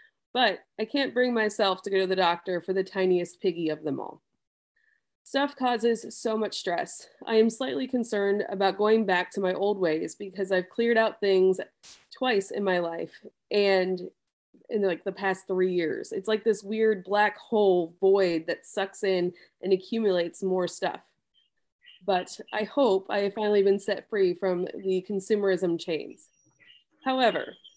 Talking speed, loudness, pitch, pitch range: 165 wpm, -27 LUFS, 195 Hz, 185-220 Hz